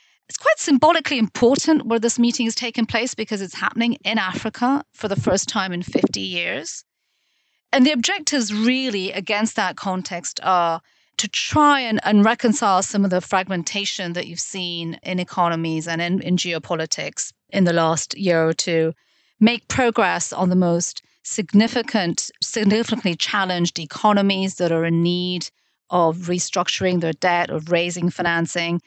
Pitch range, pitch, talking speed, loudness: 175-230 Hz, 190 Hz, 155 wpm, -20 LUFS